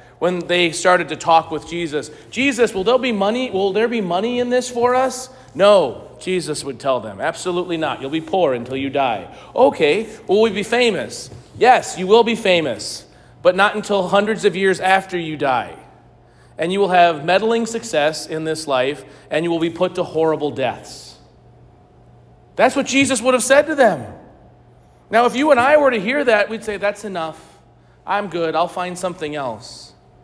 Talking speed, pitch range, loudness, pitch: 190 wpm, 160-230 Hz, -18 LUFS, 185 Hz